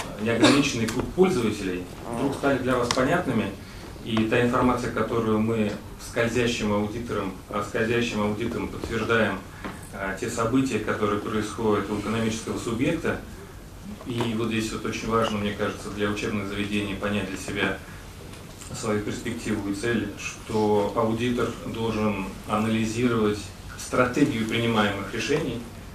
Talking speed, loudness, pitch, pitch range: 115 wpm, -26 LUFS, 110 Hz, 100-115 Hz